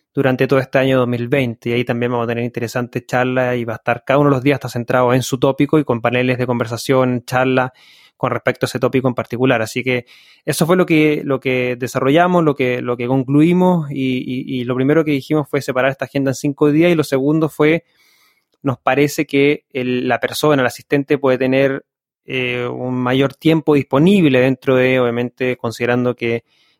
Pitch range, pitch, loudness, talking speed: 125-145 Hz, 130 Hz, -16 LUFS, 205 wpm